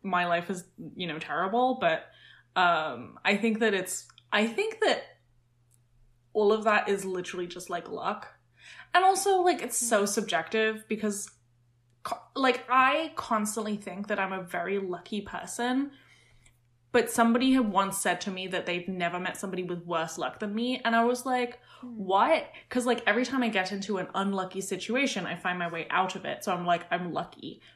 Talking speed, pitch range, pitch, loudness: 180 wpm, 175-235 Hz, 195 Hz, -28 LUFS